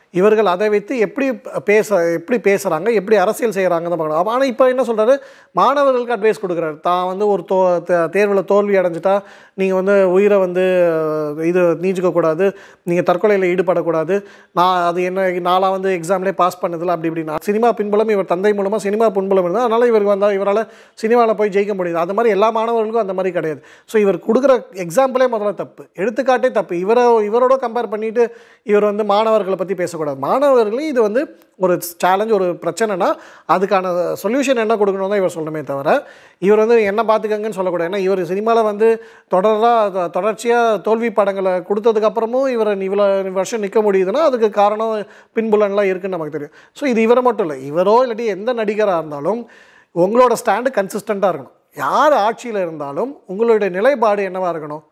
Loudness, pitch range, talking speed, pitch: -16 LUFS, 180-225 Hz, 160 wpm, 205 Hz